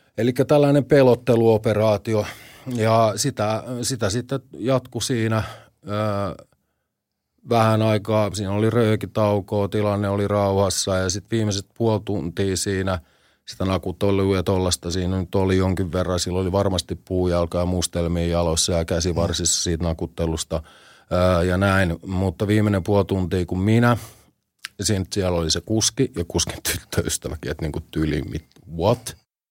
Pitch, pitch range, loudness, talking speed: 100 Hz, 90-110 Hz, -22 LUFS, 135 wpm